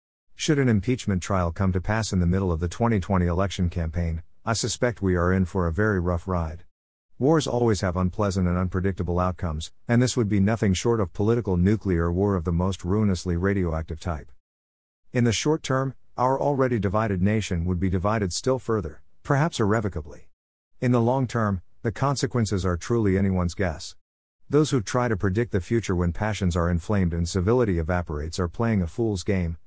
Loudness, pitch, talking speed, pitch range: -25 LUFS, 95 Hz, 185 wpm, 90-115 Hz